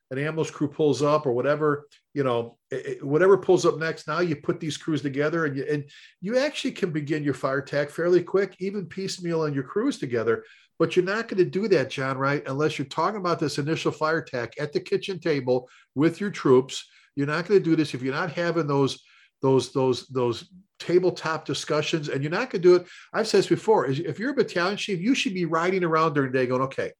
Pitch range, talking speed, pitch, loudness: 145-185 Hz, 230 wpm, 160 Hz, -25 LUFS